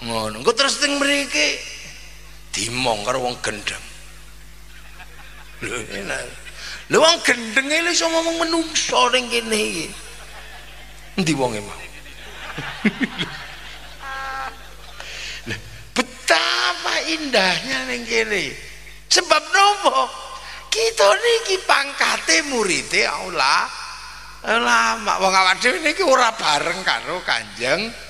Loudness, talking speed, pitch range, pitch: -19 LUFS, 95 wpm, 215-330 Hz, 270 Hz